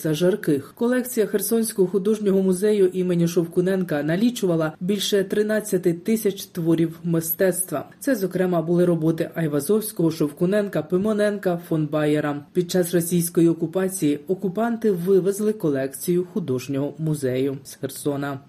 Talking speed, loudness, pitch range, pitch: 110 wpm, -22 LUFS, 160-200 Hz, 180 Hz